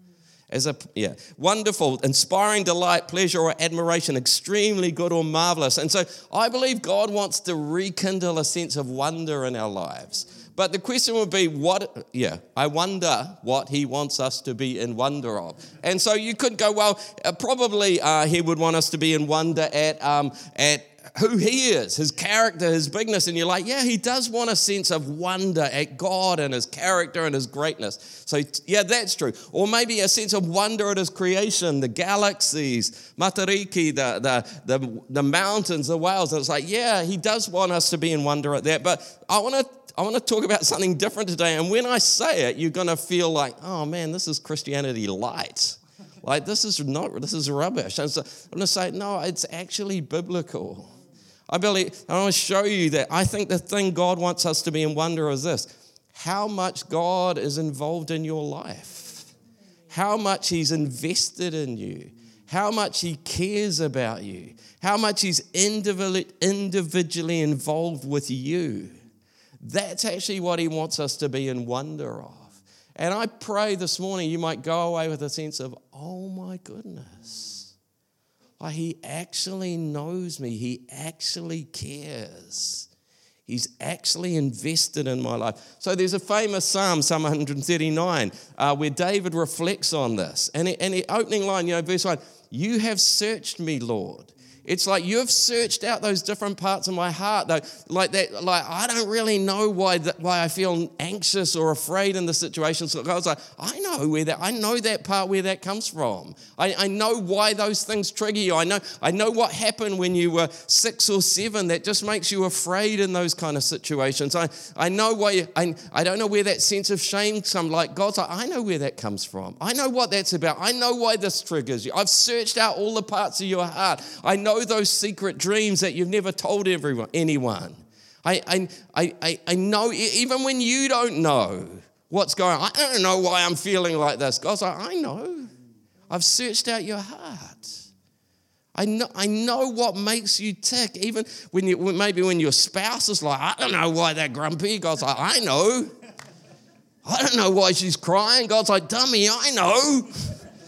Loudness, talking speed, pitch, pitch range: -23 LUFS, 195 wpm, 180 Hz, 155-205 Hz